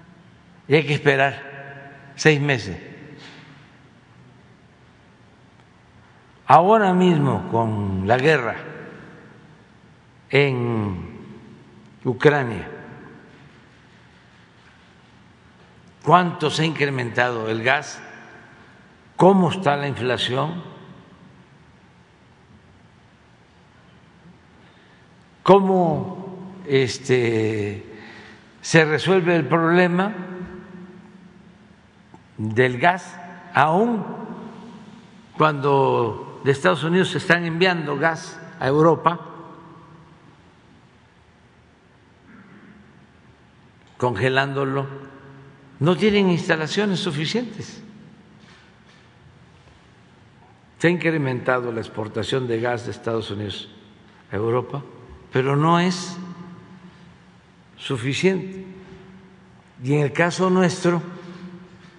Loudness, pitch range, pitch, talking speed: -20 LUFS, 135-180 Hz, 160 Hz, 65 wpm